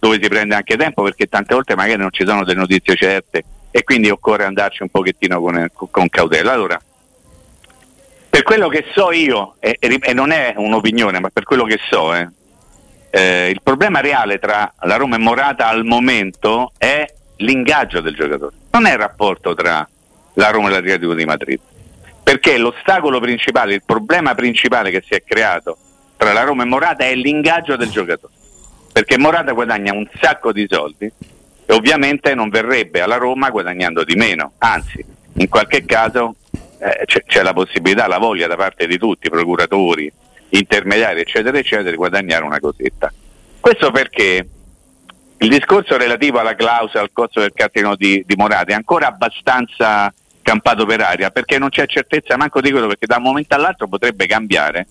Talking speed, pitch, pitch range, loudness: 175 wpm, 110 Hz, 95-135 Hz, -14 LUFS